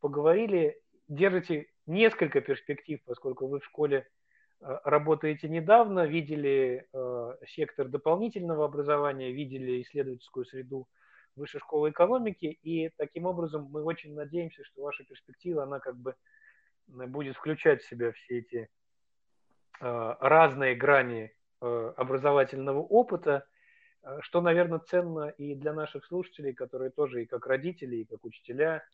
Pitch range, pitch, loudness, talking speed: 130-170 Hz, 150 Hz, -29 LUFS, 120 wpm